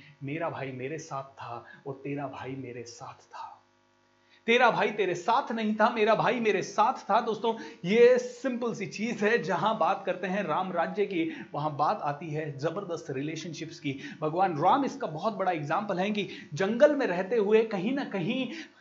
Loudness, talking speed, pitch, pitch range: -28 LUFS, 180 wpm, 195 Hz, 155-225 Hz